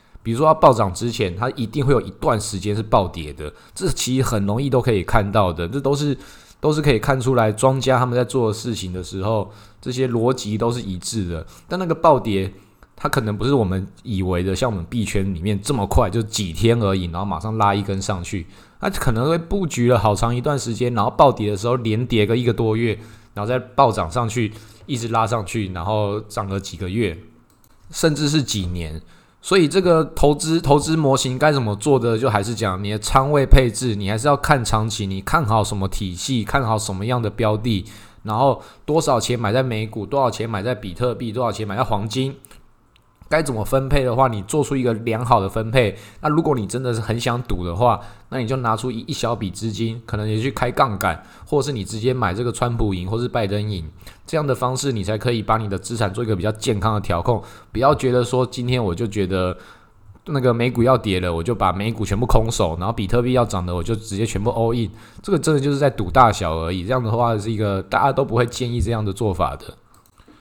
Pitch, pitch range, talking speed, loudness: 115 Hz, 105-130 Hz, 330 characters per minute, -20 LUFS